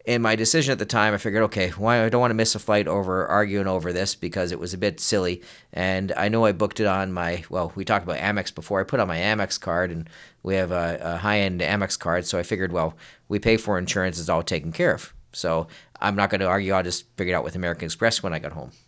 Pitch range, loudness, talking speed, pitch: 90-105 Hz, -23 LUFS, 275 wpm, 95 Hz